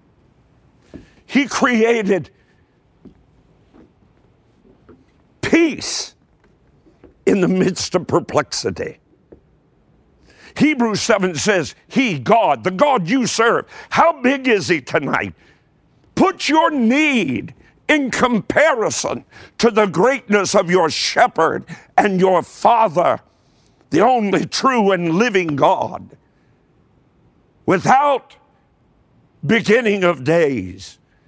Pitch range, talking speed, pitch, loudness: 180-260 Hz, 90 wpm, 215 Hz, -16 LUFS